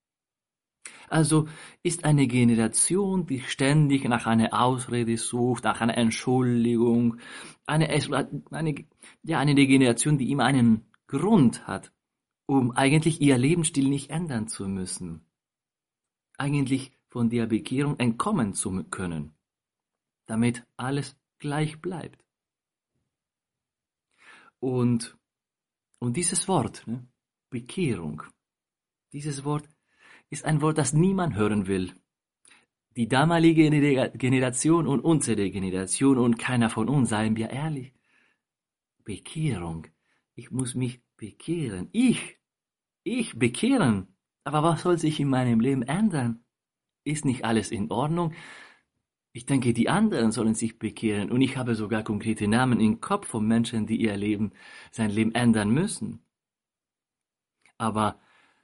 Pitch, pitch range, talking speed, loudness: 125 Hz, 115-150 Hz, 120 wpm, -25 LUFS